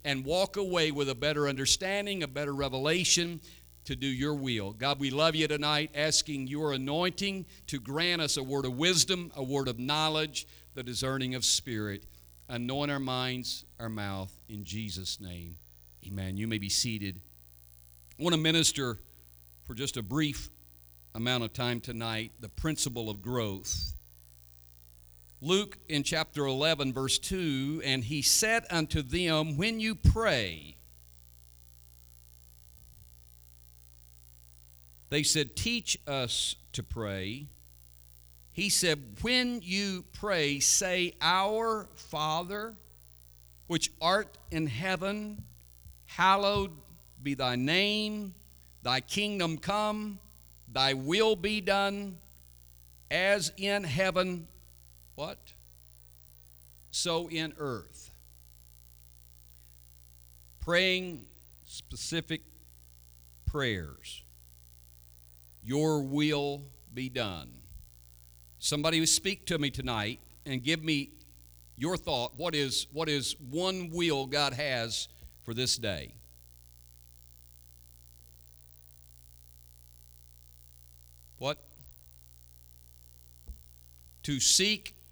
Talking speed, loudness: 105 wpm, -30 LUFS